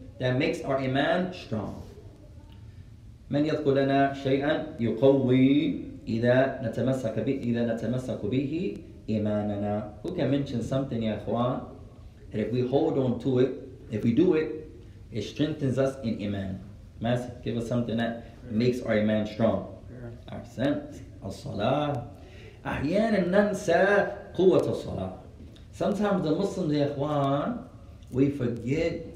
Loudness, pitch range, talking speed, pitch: -27 LUFS, 105-140 Hz, 130 wpm, 120 Hz